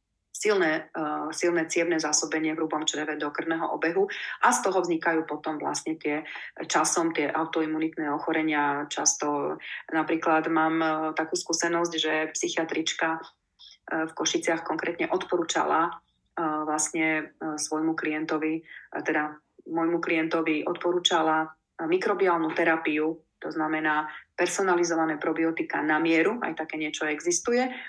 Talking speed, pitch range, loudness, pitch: 125 wpm, 155-170 Hz, -27 LUFS, 160 Hz